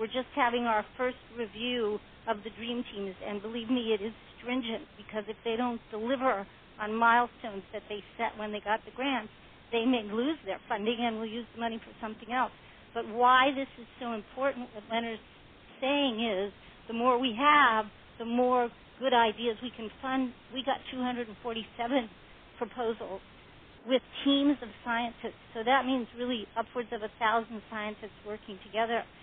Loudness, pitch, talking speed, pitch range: -31 LUFS, 230 Hz, 170 wpm, 220-250 Hz